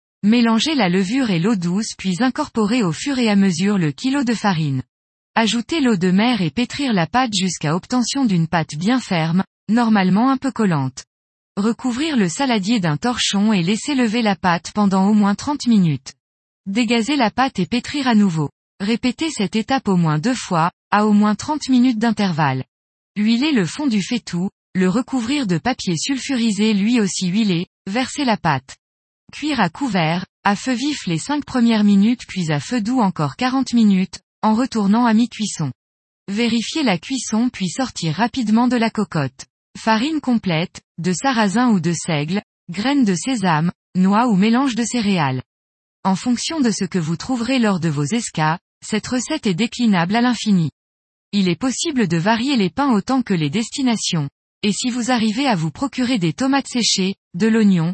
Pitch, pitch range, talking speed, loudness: 215 Hz, 185-250 Hz, 175 wpm, -19 LUFS